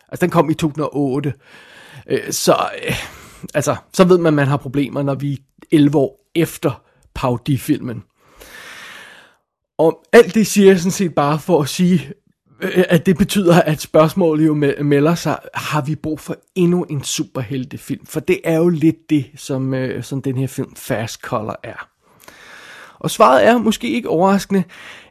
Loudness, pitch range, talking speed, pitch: -17 LUFS, 140-180 Hz, 165 wpm, 155 Hz